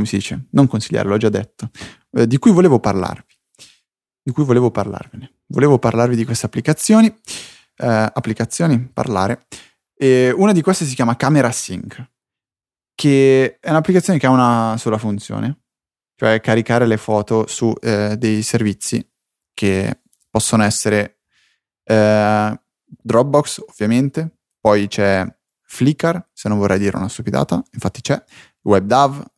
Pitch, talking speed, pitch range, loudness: 115 Hz, 135 wpm, 105-135 Hz, -16 LUFS